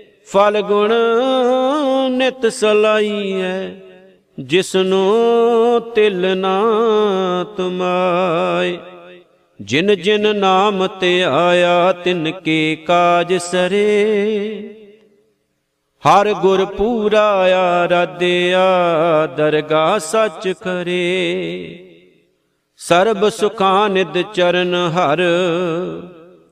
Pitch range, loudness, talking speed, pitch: 180-210 Hz, -15 LUFS, 60 wpm, 190 Hz